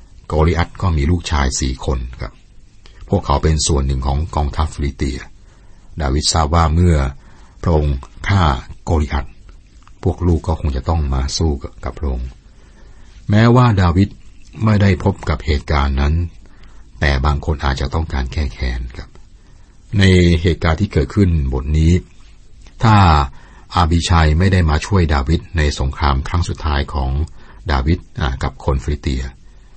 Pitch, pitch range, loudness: 80 Hz, 70-90 Hz, -17 LUFS